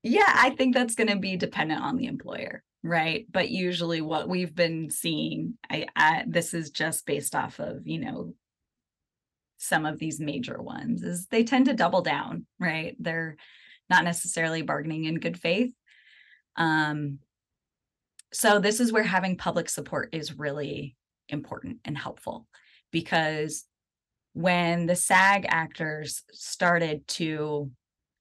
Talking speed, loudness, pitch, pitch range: 145 wpm, -27 LUFS, 170 Hz, 155-200 Hz